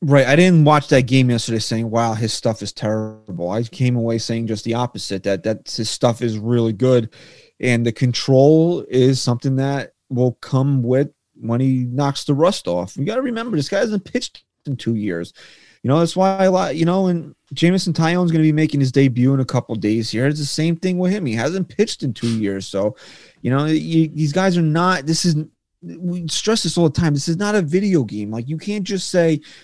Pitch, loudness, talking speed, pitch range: 135 Hz, -18 LUFS, 235 wpm, 115-165 Hz